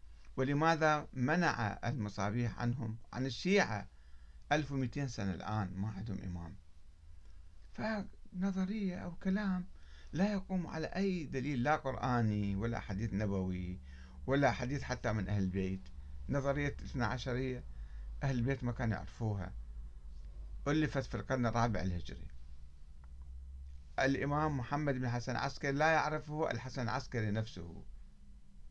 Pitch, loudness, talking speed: 115 Hz, -37 LUFS, 115 wpm